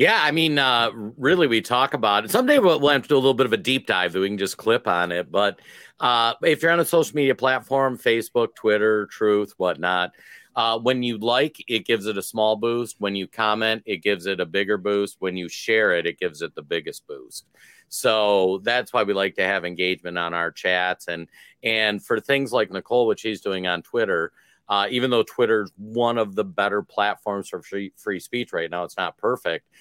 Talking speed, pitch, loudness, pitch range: 225 wpm, 110 Hz, -22 LUFS, 100-130 Hz